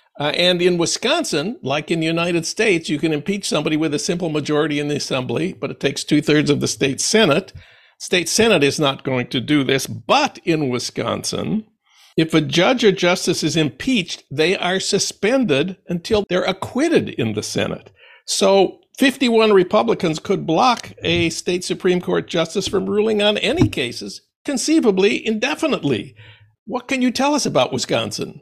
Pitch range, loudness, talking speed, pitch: 155-210 Hz, -18 LUFS, 170 wpm, 180 Hz